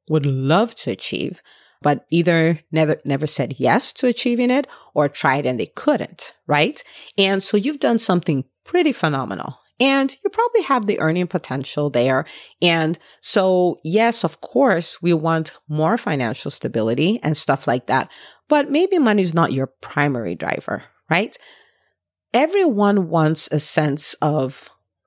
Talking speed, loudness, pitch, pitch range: 150 wpm, -19 LUFS, 170 Hz, 150-230 Hz